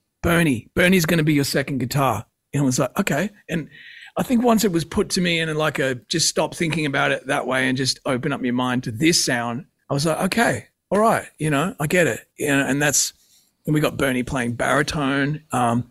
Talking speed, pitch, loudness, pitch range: 240 wpm, 145 Hz, -21 LUFS, 130-165 Hz